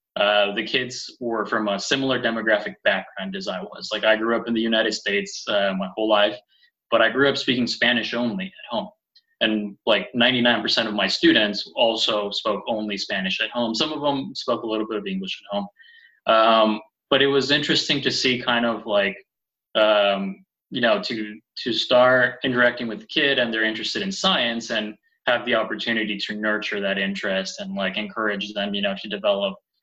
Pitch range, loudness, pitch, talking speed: 105-140 Hz, -22 LUFS, 115 Hz, 195 wpm